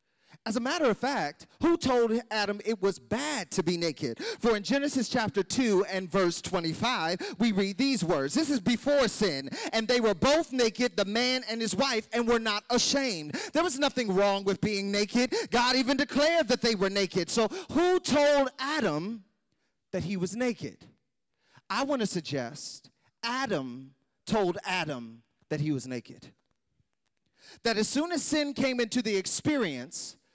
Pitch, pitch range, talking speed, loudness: 225 Hz, 190-255 Hz, 170 wpm, -28 LUFS